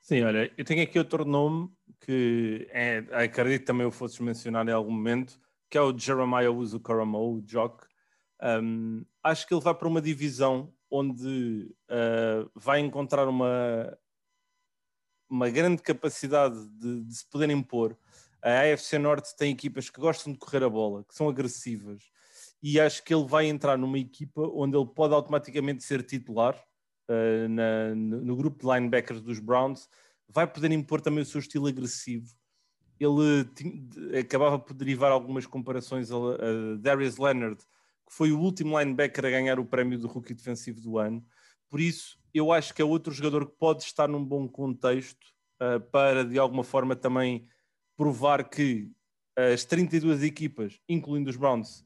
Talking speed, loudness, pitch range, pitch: 165 wpm, -28 LUFS, 120-150 Hz, 130 Hz